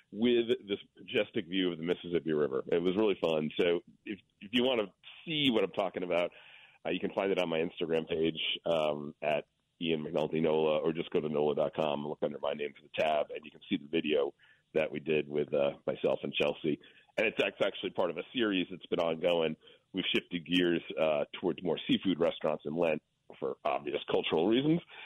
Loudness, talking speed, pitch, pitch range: -32 LUFS, 210 wpm, 80 Hz, 75-95 Hz